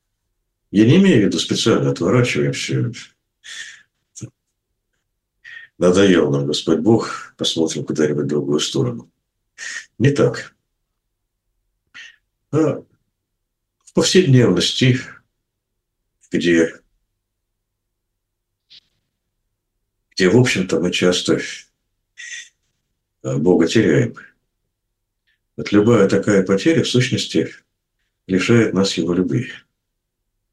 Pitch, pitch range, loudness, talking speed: 105 Hz, 90-115 Hz, -17 LUFS, 75 wpm